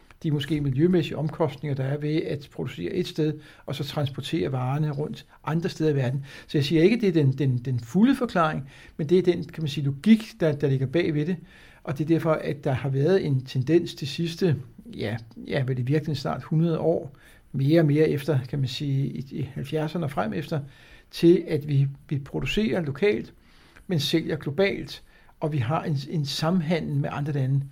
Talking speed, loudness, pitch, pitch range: 210 wpm, -25 LUFS, 155 Hz, 140-170 Hz